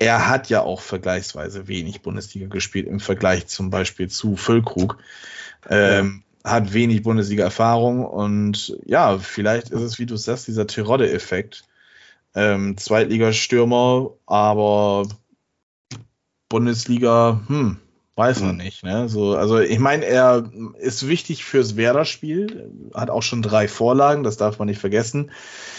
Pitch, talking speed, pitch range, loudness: 110 Hz, 130 wpm, 100-120 Hz, -20 LUFS